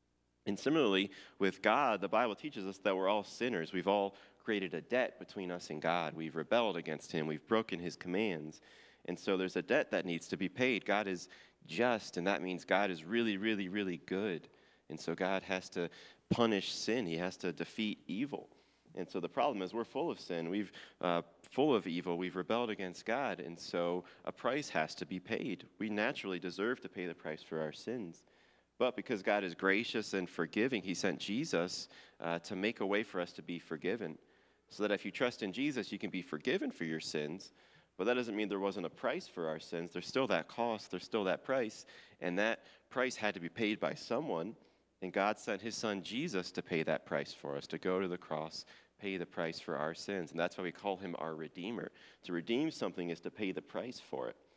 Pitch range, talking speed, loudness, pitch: 85-105 Hz, 220 wpm, -37 LUFS, 95 Hz